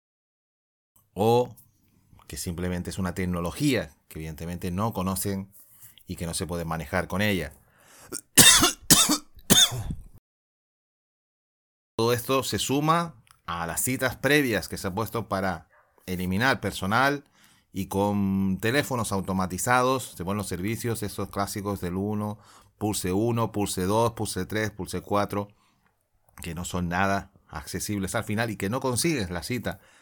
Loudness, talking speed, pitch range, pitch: -25 LUFS, 130 wpm, 90-115 Hz, 100 Hz